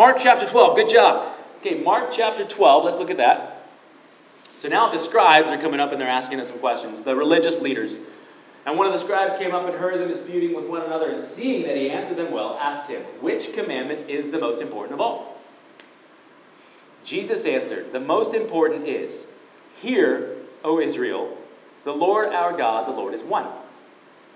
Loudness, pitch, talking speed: -21 LUFS, 195 Hz, 190 wpm